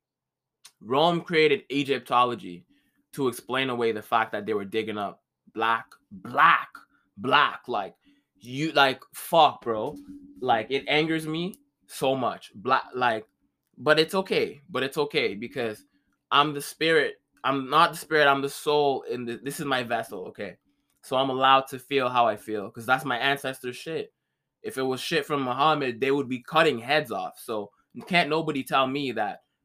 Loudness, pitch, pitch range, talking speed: -25 LUFS, 140 Hz, 130-160 Hz, 170 wpm